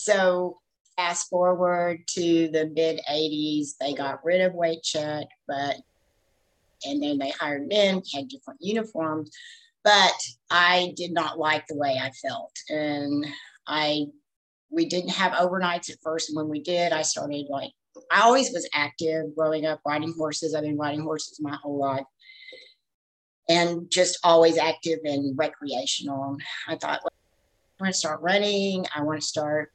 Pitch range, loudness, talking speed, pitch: 150-180 Hz, -25 LUFS, 160 wpm, 155 Hz